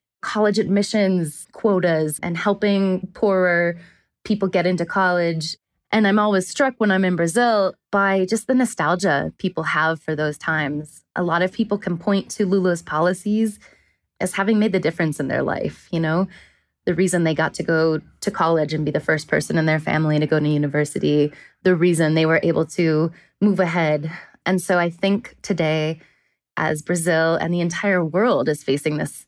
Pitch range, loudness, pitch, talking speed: 160-195 Hz, -20 LUFS, 175 Hz, 180 wpm